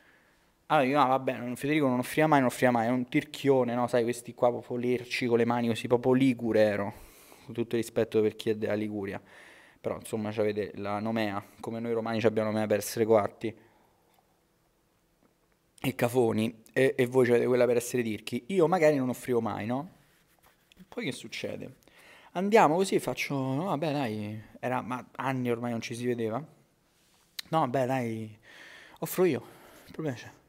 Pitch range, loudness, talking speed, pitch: 110-130 Hz, -29 LUFS, 180 wpm, 120 Hz